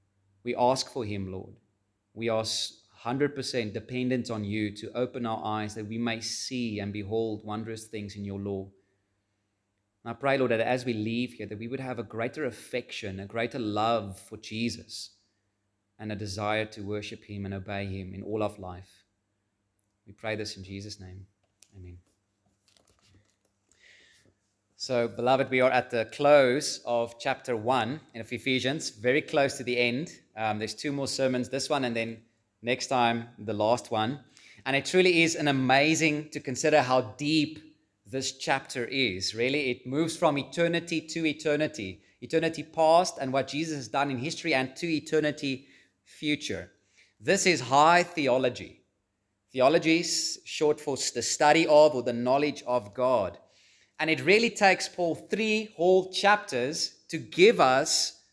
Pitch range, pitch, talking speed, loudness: 105-140 Hz, 120 Hz, 165 wpm, -27 LUFS